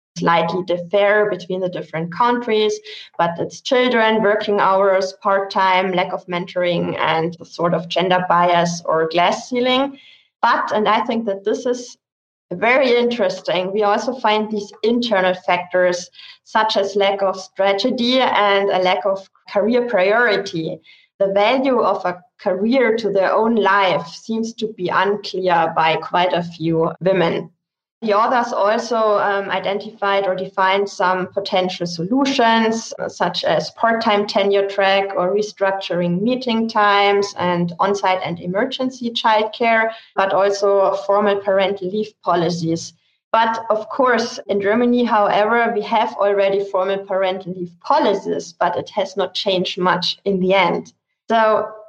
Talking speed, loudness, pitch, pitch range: 140 wpm, -18 LUFS, 200 Hz, 185-220 Hz